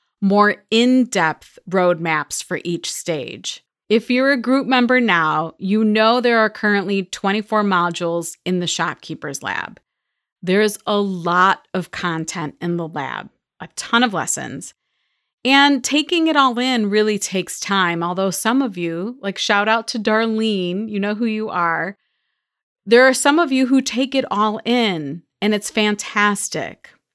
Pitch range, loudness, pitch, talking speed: 180-245 Hz, -18 LUFS, 210 Hz, 155 wpm